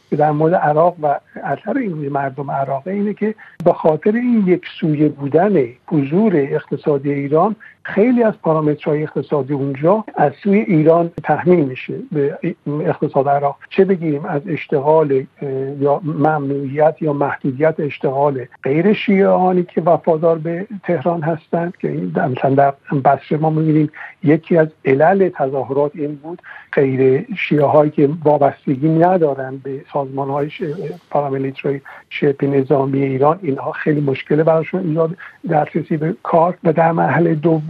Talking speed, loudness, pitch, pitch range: 135 wpm, -17 LUFS, 155 Hz, 140-170 Hz